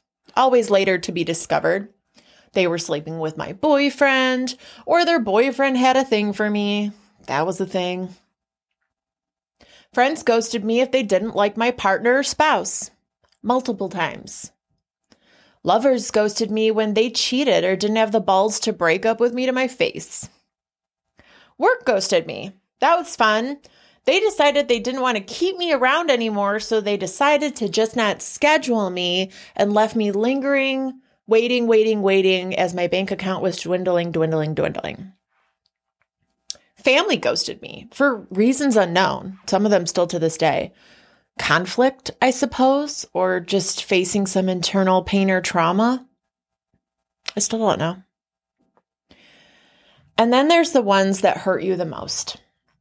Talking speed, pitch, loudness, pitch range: 150 wpm, 210 Hz, -19 LUFS, 185-255 Hz